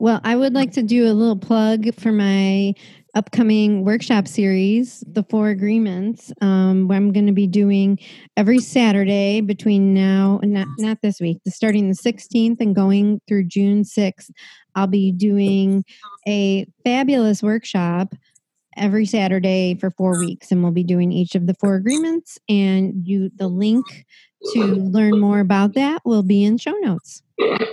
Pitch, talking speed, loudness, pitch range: 205 Hz, 160 wpm, -18 LUFS, 195-225 Hz